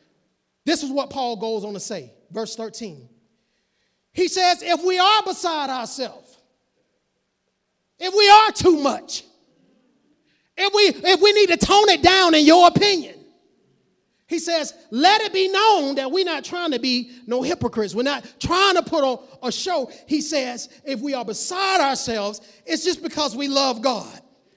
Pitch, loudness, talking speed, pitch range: 300 Hz, -19 LUFS, 170 wpm, 250-365 Hz